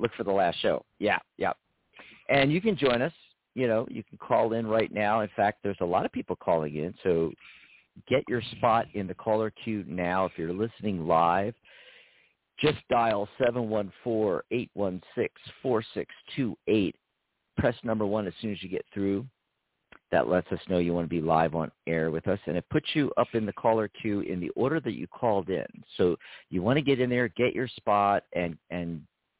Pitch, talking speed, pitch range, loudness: 105 Hz, 210 wpm, 90-115 Hz, -28 LUFS